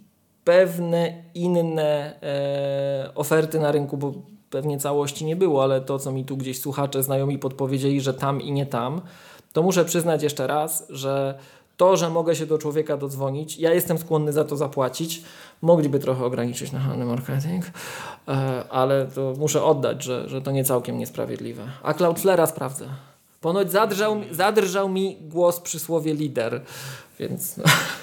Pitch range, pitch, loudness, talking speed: 135-170 Hz, 150 Hz, -23 LUFS, 155 wpm